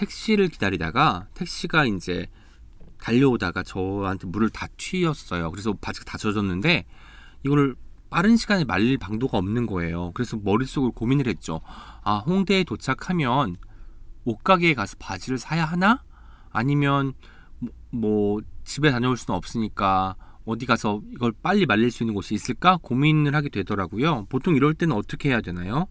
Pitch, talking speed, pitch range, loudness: 115 Hz, 340 characters per minute, 100-145 Hz, -24 LUFS